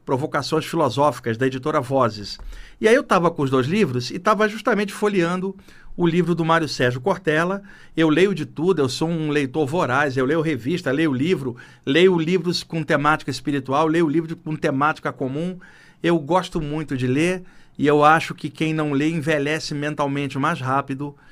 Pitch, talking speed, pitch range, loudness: 155 Hz, 175 wpm, 140-175 Hz, -21 LUFS